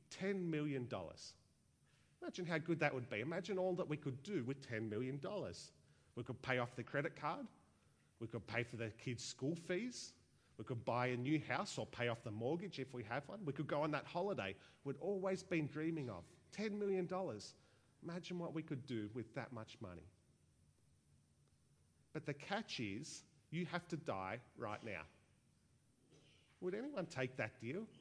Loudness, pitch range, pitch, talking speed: -45 LUFS, 115-165 Hz, 135 Hz, 180 wpm